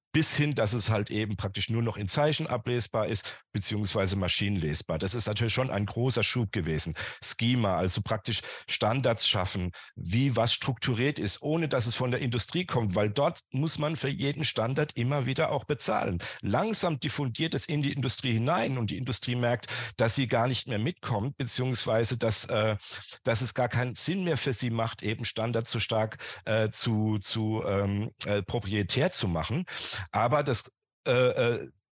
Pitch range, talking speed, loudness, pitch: 105-135 Hz, 180 wpm, -28 LUFS, 120 Hz